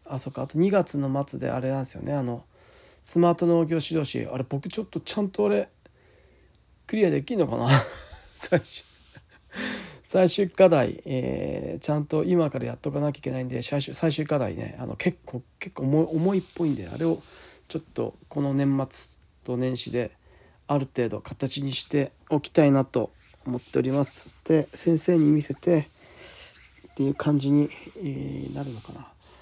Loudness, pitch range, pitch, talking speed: -26 LUFS, 125-160 Hz, 140 Hz, 300 characters per minute